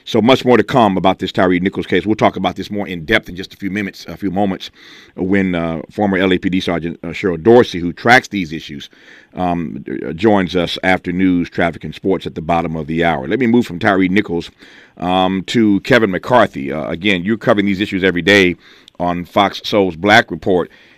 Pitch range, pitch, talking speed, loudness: 85-100 Hz, 95 Hz, 210 wpm, -15 LUFS